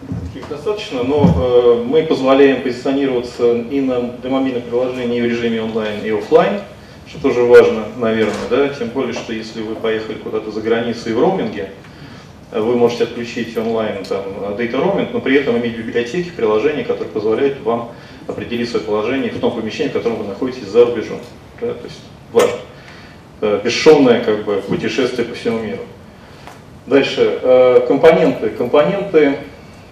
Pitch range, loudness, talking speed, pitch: 115-175 Hz, -16 LUFS, 150 wpm, 120 Hz